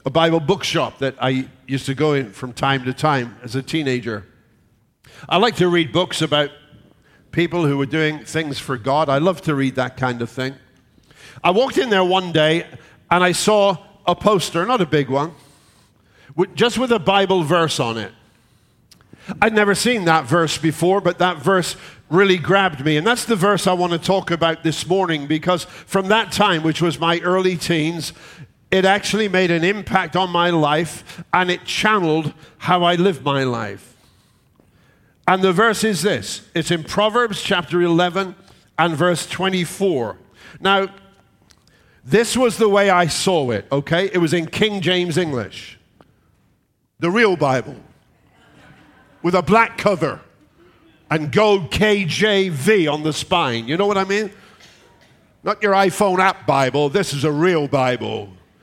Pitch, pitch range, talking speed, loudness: 170 Hz, 140-190 Hz, 165 wpm, -18 LUFS